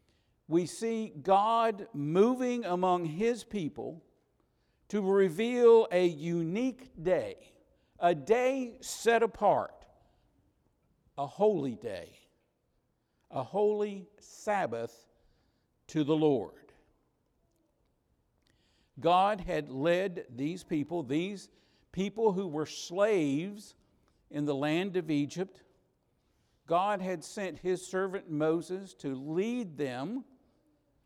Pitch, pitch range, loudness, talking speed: 185 Hz, 155-210 Hz, -31 LUFS, 95 wpm